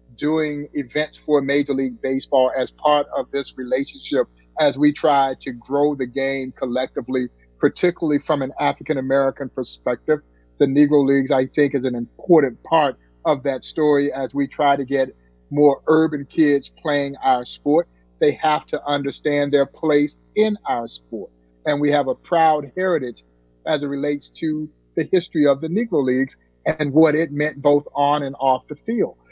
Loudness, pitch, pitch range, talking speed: -20 LUFS, 140 Hz, 130-150 Hz, 170 wpm